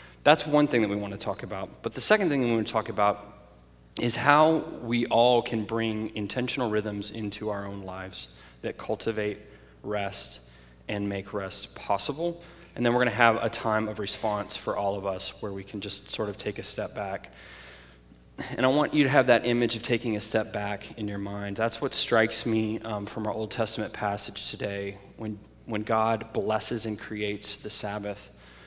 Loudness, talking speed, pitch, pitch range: -27 LUFS, 205 wpm, 105 Hz, 100-115 Hz